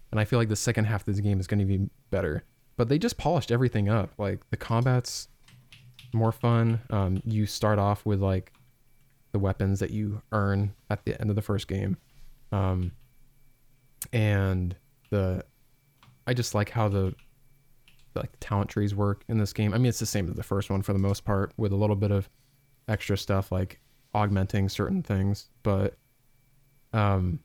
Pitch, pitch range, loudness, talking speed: 105 Hz, 100-125 Hz, -28 LUFS, 190 wpm